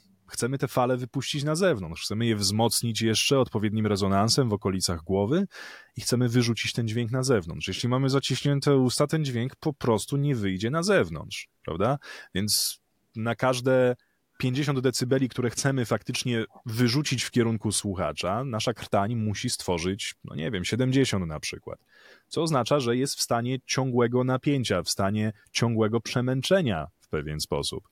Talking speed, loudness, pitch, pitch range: 155 wpm, -26 LUFS, 120 Hz, 110-130 Hz